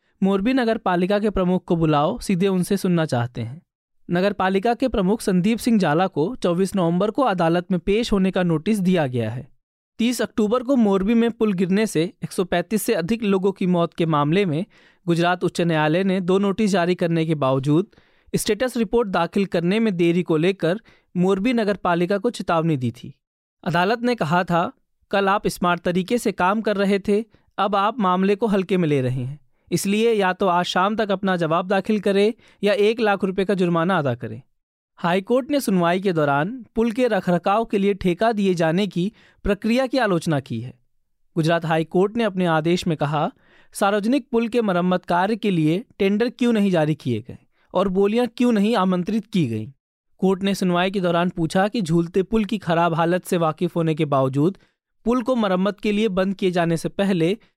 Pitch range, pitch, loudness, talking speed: 170-210 Hz, 190 Hz, -21 LUFS, 195 wpm